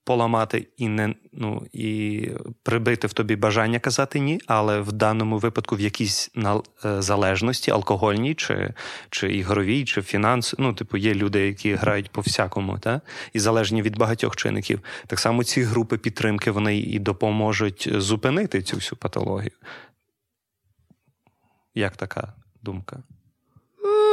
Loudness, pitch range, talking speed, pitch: -23 LUFS, 105-115 Hz, 130 wpm, 110 Hz